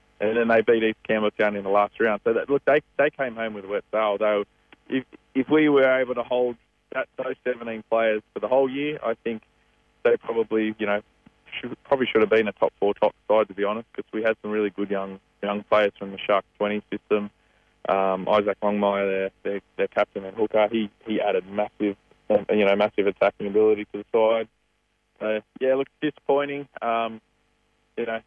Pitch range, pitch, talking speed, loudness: 105-115 Hz, 110 Hz, 210 wpm, -24 LUFS